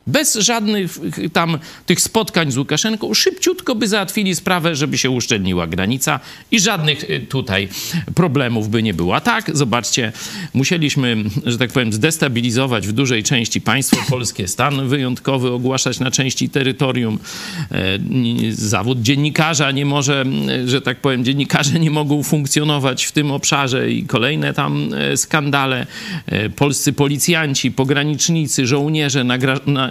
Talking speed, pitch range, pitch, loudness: 130 wpm, 125-155 Hz, 140 Hz, -17 LUFS